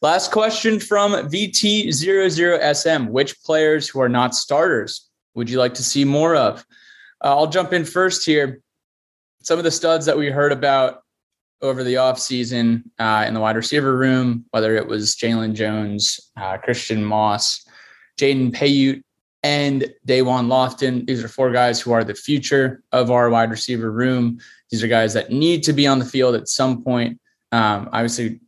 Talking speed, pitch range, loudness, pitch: 175 wpm, 115-145 Hz, -18 LUFS, 130 Hz